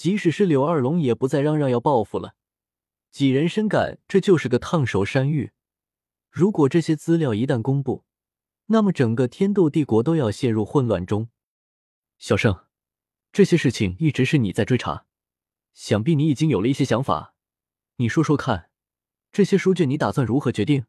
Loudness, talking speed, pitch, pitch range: -21 LUFS, 260 characters per minute, 140 Hz, 120-165 Hz